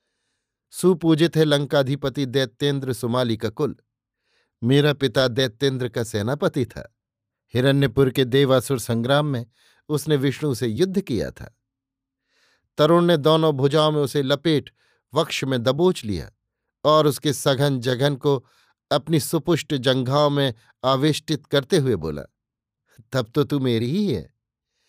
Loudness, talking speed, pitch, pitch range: -21 LUFS, 130 wpm, 140 Hz, 130-150 Hz